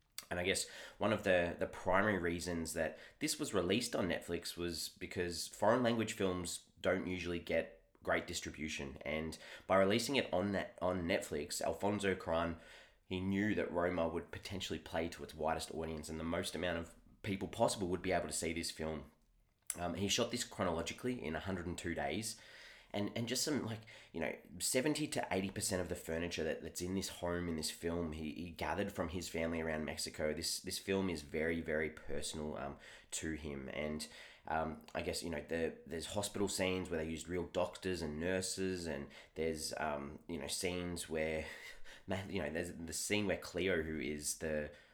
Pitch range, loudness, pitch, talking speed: 80-95 Hz, -39 LUFS, 85 Hz, 195 wpm